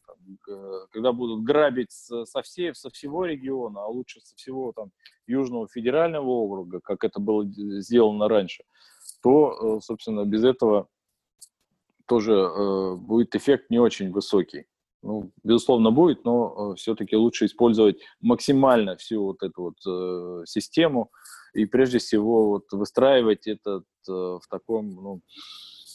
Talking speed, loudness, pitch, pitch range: 125 wpm, -24 LUFS, 110 Hz, 100-120 Hz